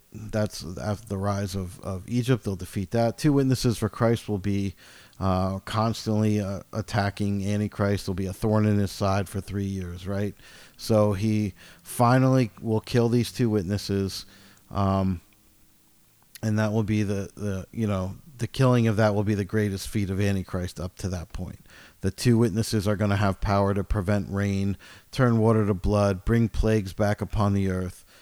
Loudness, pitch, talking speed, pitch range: -26 LUFS, 105 Hz, 180 wpm, 100-110 Hz